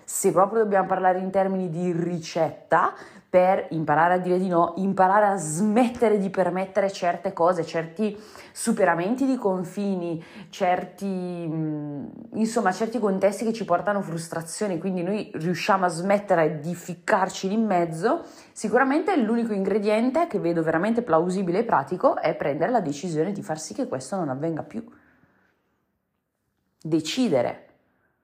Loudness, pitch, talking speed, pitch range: -24 LUFS, 190 Hz, 140 wpm, 170-210 Hz